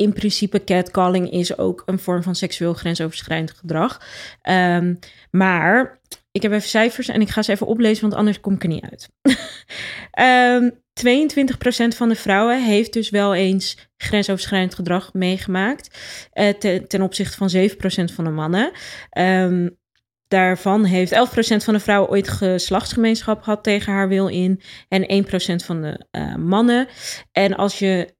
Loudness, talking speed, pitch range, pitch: -19 LUFS, 155 wpm, 185-215 Hz, 195 Hz